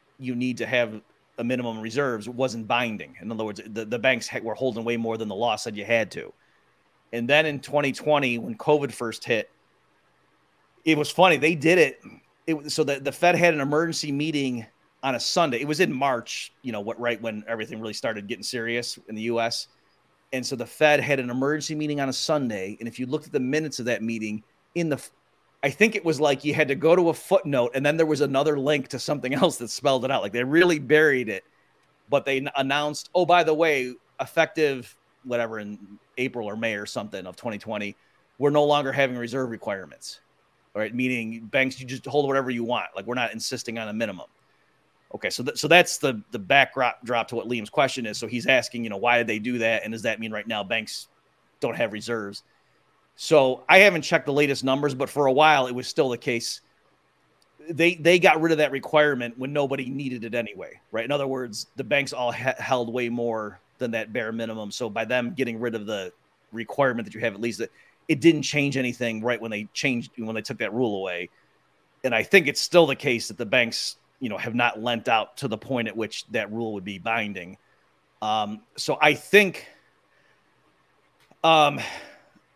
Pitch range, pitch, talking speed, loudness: 115-145 Hz, 130 Hz, 215 wpm, -24 LUFS